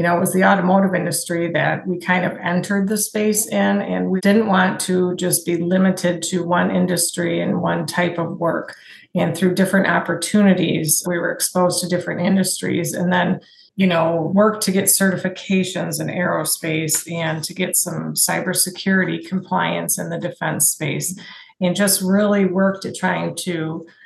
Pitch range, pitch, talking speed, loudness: 170-190 Hz, 180 Hz, 170 wpm, -18 LUFS